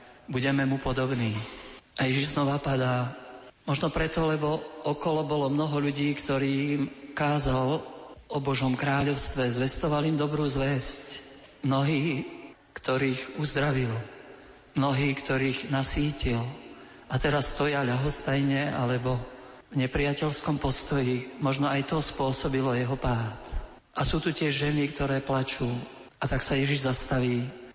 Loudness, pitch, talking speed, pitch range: -28 LUFS, 140 Hz, 120 wpm, 130-145 Hz